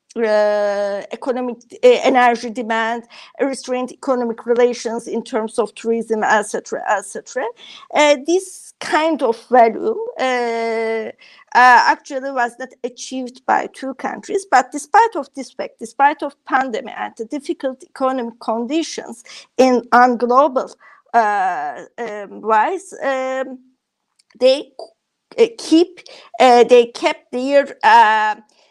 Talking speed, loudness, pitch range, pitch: 120 wpm, -17 LUFS, 235-310 Hz, 255 Hz